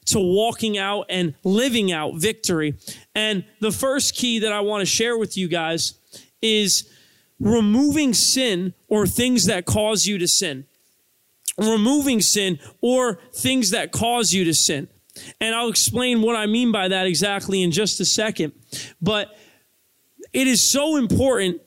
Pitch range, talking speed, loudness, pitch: 180-230 Hz, 150 wpm, -20 LUFS, 210 Hz